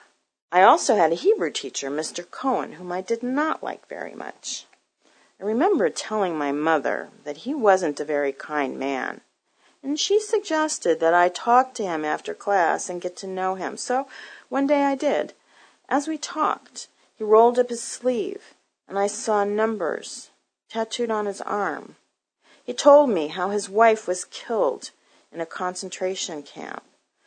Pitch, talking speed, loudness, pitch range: 210 Hz, 165 wpm, -23 LUFS, 180-265 Hz